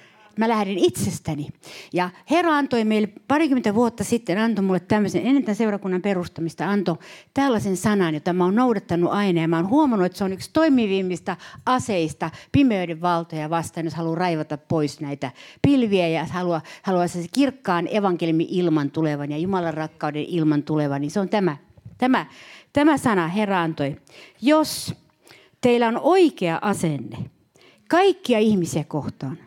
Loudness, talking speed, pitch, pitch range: -22 LUFS, 150 wpm, 180 Hz, 165-225 Hz